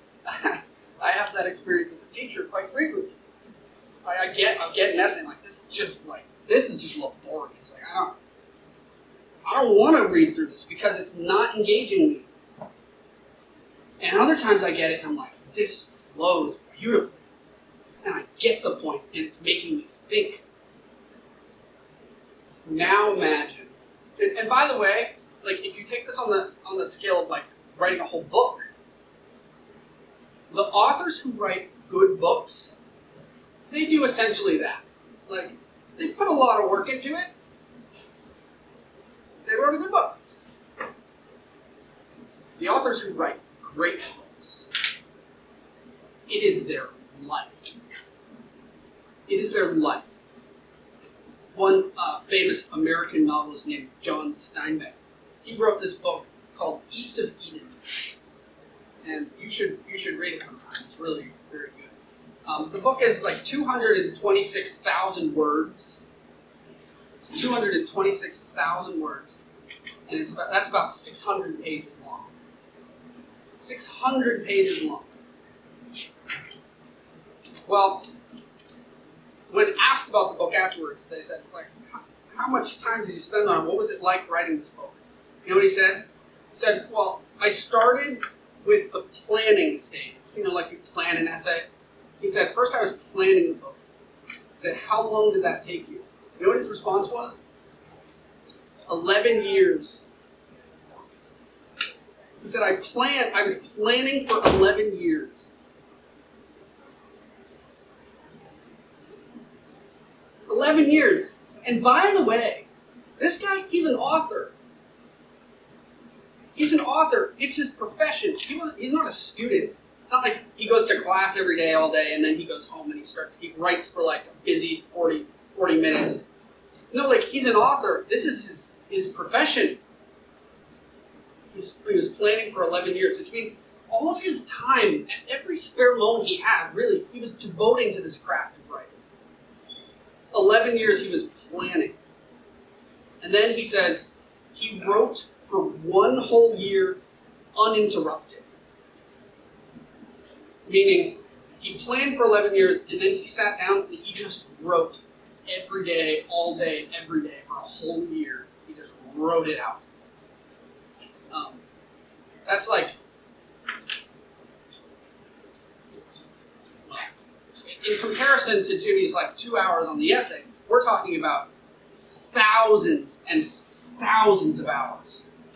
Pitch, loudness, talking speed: 325 Hz, -24 LUFS, 145 wpm